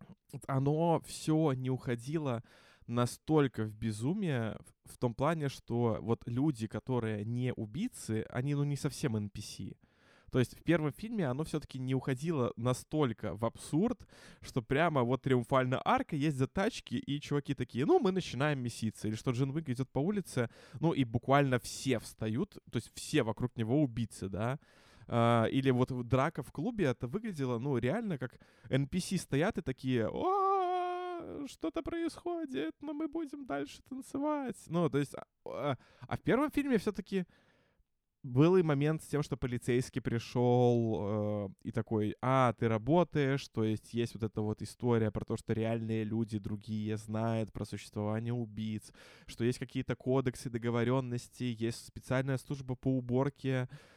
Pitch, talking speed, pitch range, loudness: 130 Hz, 155 wpm, 115-155 Hz, -34 LUFS